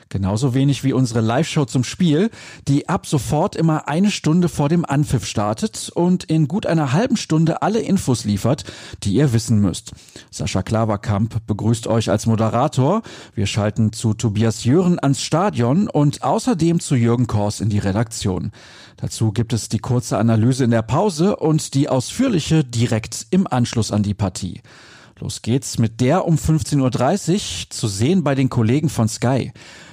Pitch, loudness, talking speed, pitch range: 130 Hz, -19 LUFS, 165 wpm, 110-155 Hz